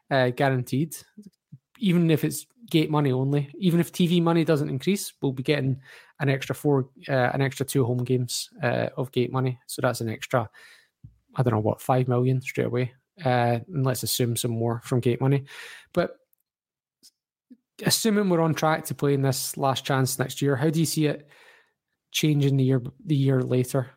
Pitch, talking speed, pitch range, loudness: 135 Hz, 185 wpm, 130-155 Hz, -25 LUFS